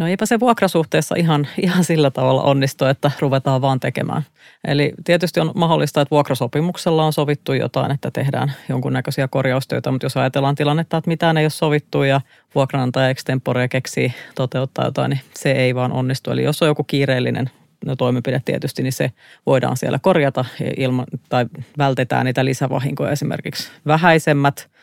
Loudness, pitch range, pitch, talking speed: -19 LUFS, 130-155 Hz, 140 Hz, 155 wpm